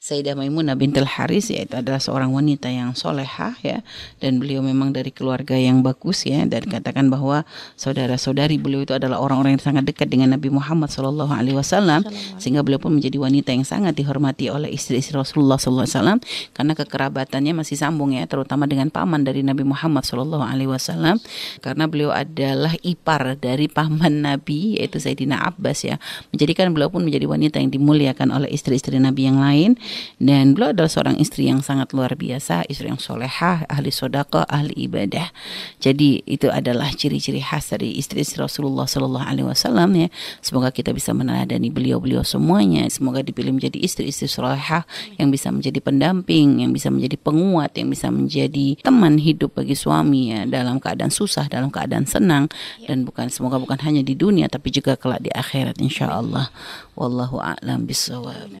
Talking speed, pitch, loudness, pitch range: 165 wpm, 135 Hz, -20 LUFS, 130-150 Hz